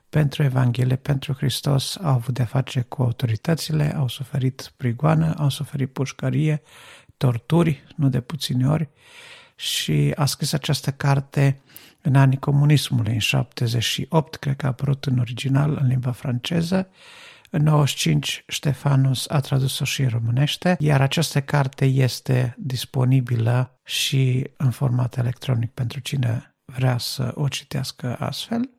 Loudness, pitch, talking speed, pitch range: -22 LUFS, 135 Hz, 135 wpm, 125-150 Hz